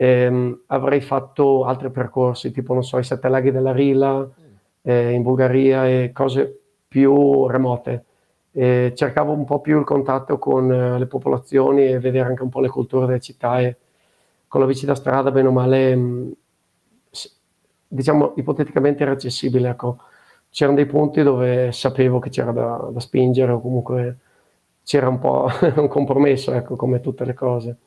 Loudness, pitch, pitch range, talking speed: -19 LUFS, 130 Hz, 125-135 Hz, 160 wpm